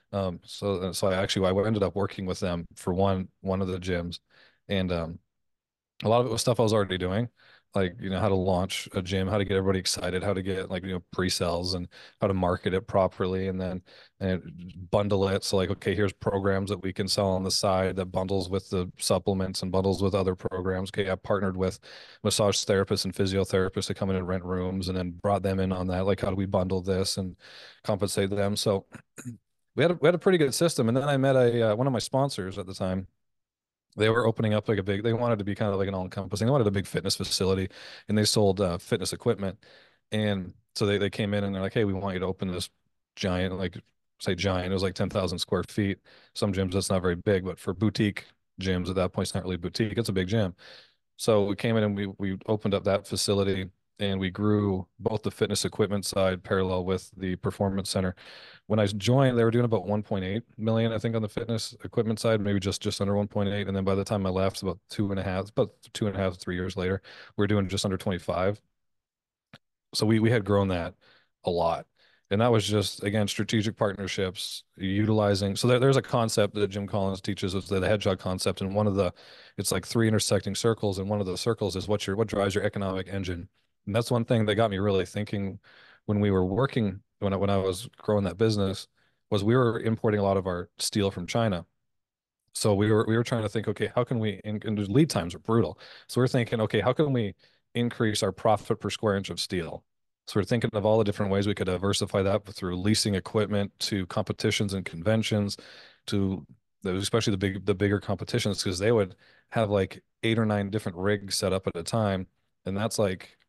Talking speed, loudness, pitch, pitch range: 235 wpm, -28 LUFS, 100 Hz, 95-110 Hz